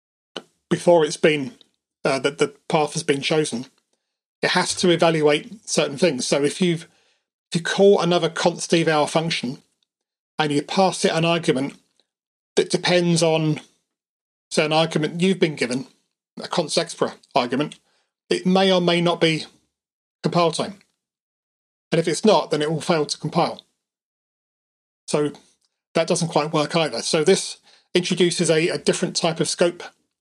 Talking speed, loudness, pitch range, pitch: 155 wpm, -21 LUFS, 155-180 Hz, 165 Hz